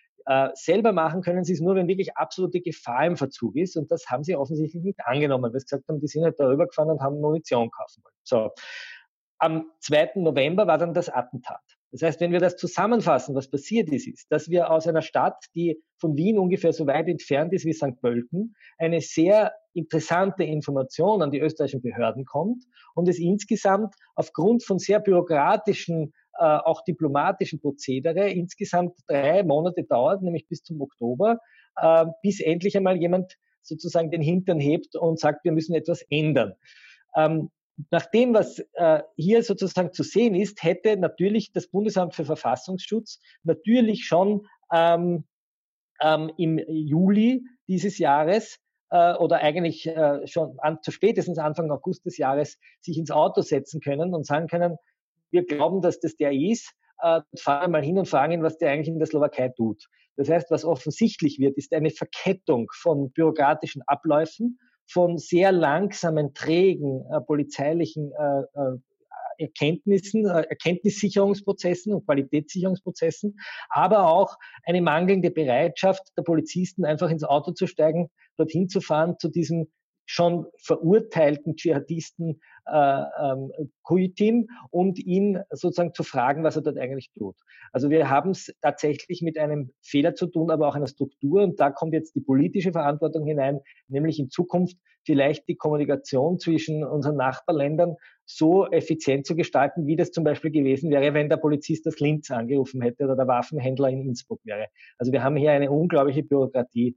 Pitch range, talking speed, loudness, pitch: 150-180 Hz, 155 wpm, -24 LUFS, 165 Hz